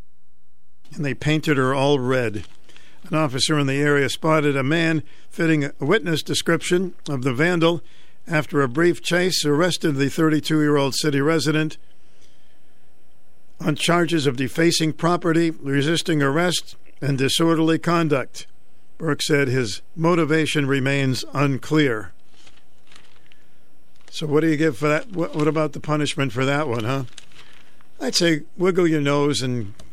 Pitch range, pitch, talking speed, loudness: 140-165 Hz, 150 Hz, 140 wpm, -21 LUFS